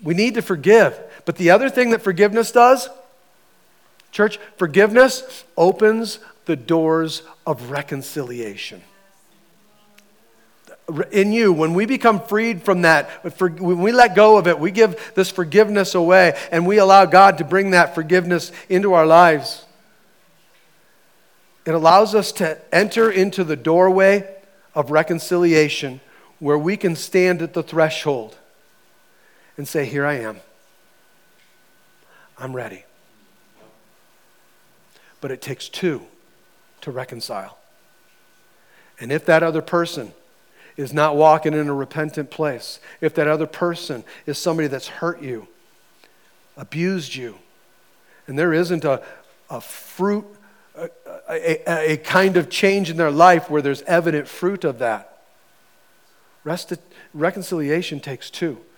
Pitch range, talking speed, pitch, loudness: 155-195 Hz, 130 wpm, 175 Hz, -17 LUFS